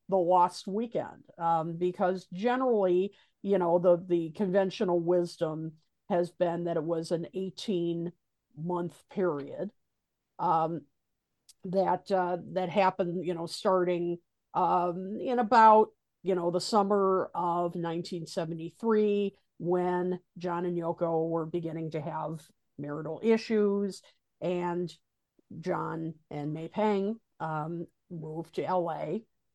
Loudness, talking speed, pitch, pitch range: -30 LUFS, 120 wpm, 175 Hz, 165-190 Hz